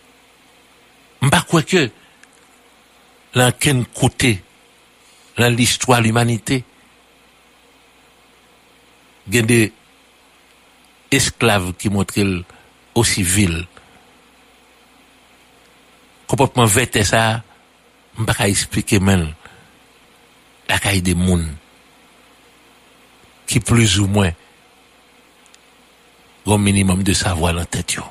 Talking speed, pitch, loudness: 80 wpm, 120 Hz, -17 LUFS